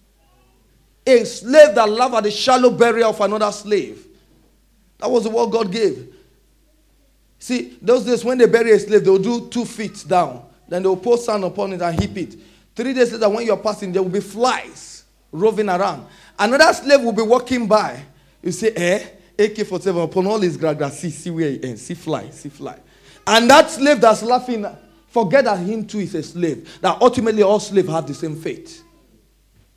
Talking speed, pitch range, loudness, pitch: 195 wpm, 185-240 Hz, -17 LUFS, 215 Hz